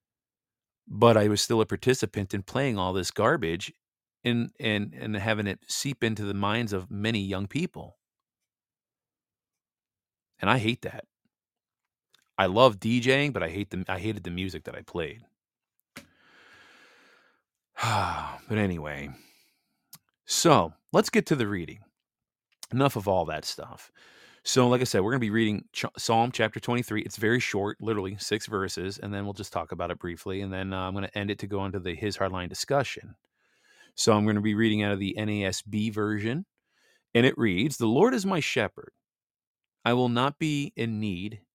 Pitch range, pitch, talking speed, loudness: 95-120 Hz, 105 Hz, 175 wpm, -27 LUFS